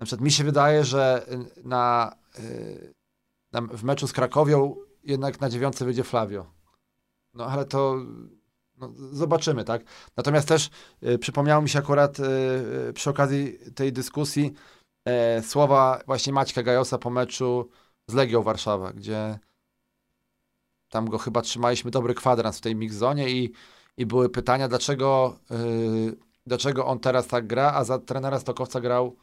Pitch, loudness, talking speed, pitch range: 130 Hz, -25 LUFS, 150 wpm, 120-140 Hz